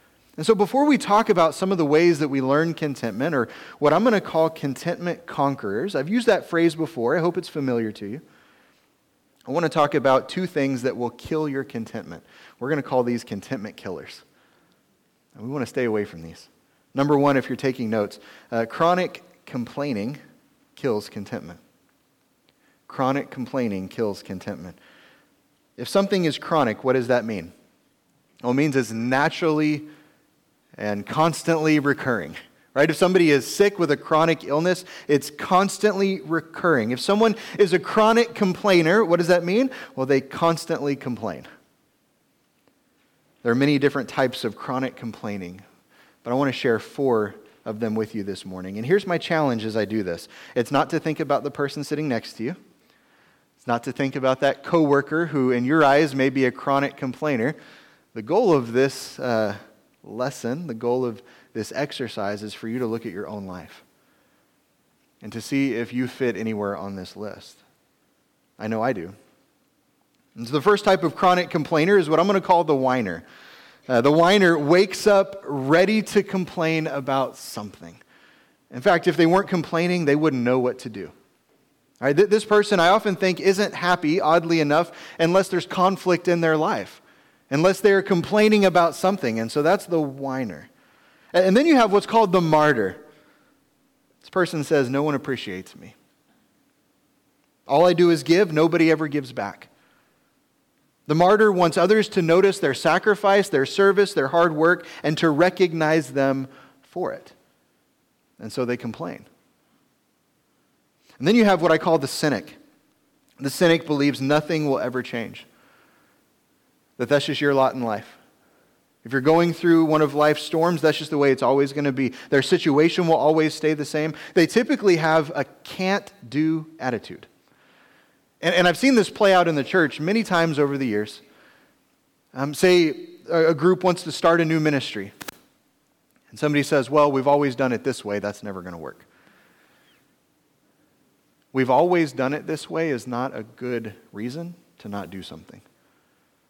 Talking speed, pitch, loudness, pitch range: 175 wpm, 150 Hz, -21 LUFS, 130-175 Hz